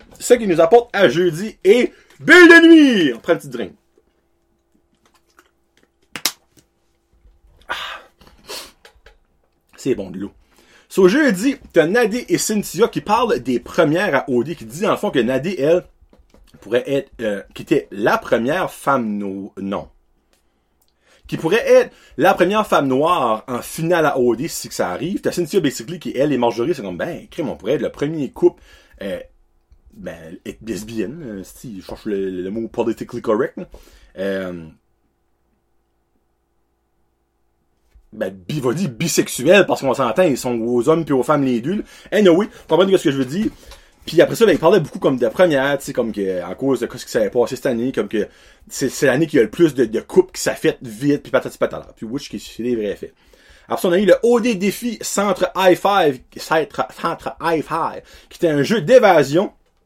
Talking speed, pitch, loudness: 185 wpm, 135 Hz, -17 LUFS